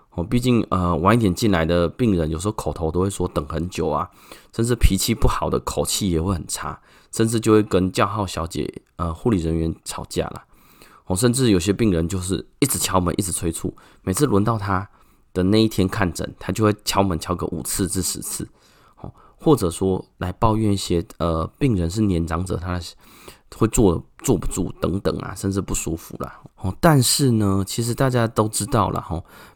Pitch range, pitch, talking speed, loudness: 85-110 Hz, 95 Hz, 280 characters per minute, -21 LUFS